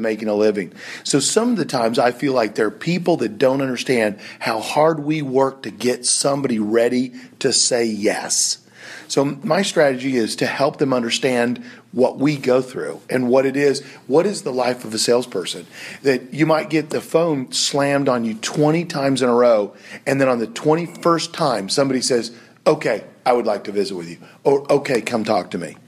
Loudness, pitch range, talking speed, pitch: -19 LUFS, 120-150 Hz, 200 wpm, 130 Hz